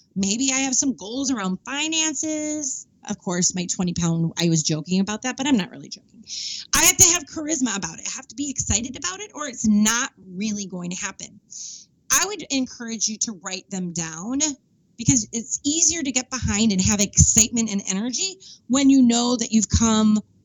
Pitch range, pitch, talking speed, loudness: 195-270 Hz, 230 Hz, 200 wpm, -21 LUFS